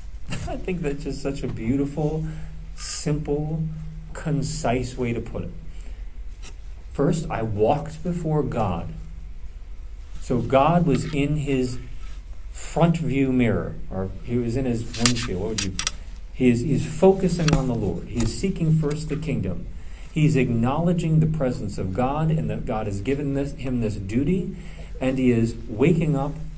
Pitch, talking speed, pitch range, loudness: 125 Hz, 150 wpm, 95-150 Hz, -24 LUFS